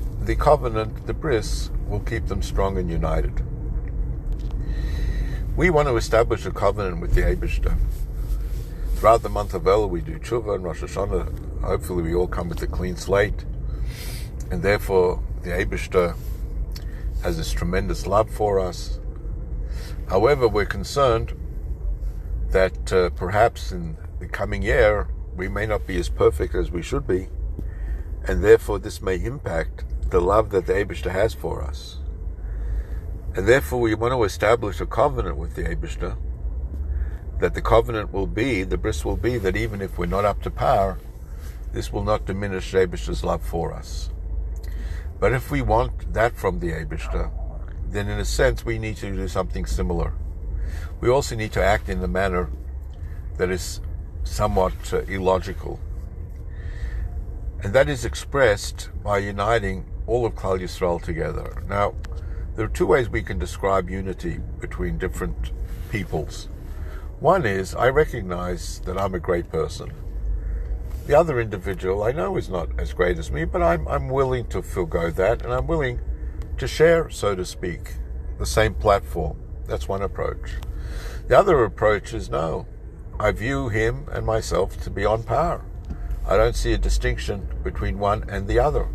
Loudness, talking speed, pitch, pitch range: -24 LUFS, 160 wpm, 90 Hz, 75-100 Hz